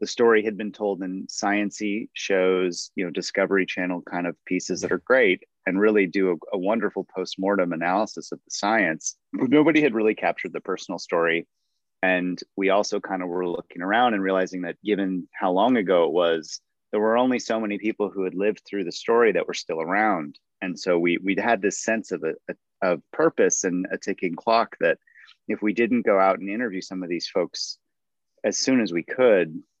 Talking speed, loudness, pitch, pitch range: 205 wpm, -24 LUFS, 95 Hz, 90-110 Hz